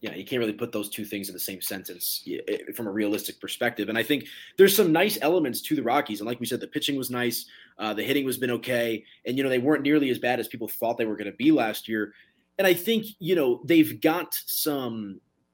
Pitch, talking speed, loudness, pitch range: 120 Hz, 255 wpm, -26 LUFS, 110-155 Hz